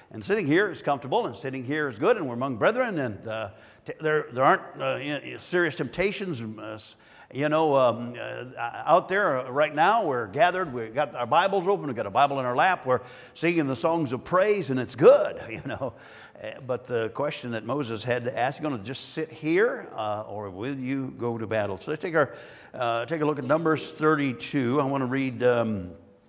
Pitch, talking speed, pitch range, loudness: 135 Hz, 215 wpm, 120-155 Hz, -26 LUFS